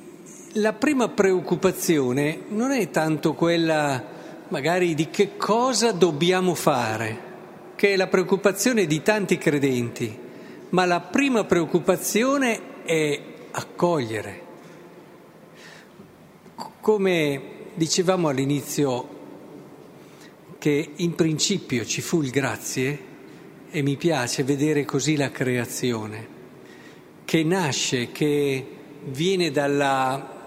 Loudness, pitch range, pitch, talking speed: -23 LUFS, 140-190 Hz, 165 Hz, 95 wpm